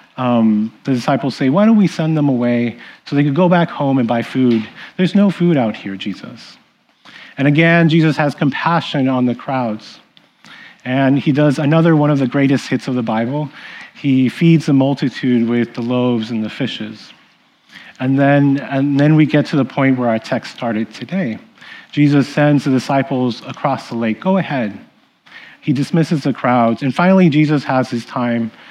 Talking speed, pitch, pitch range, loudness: 185 wpm, 140 Hz, 125-155 Hz, -15 LUFS